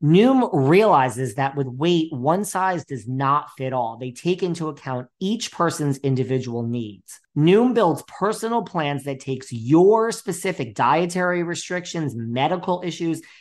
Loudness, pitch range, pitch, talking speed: -21 LUFS, 130-180 Hz, 160 Hz, 140 wpm